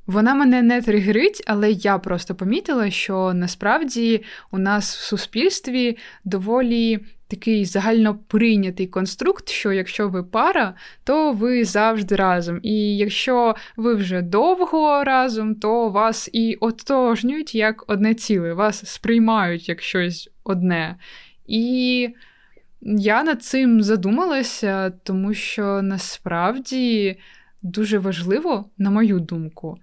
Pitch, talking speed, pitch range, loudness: 215 Hz, 115 wpm, 195-235 Hz, -20 LUFS